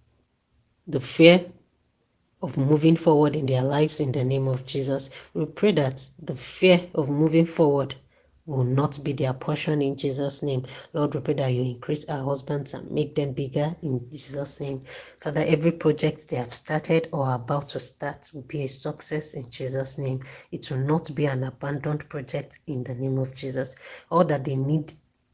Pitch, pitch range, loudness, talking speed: 145 Hz, 135-155 Hz, -25 LUFS, 185 wpm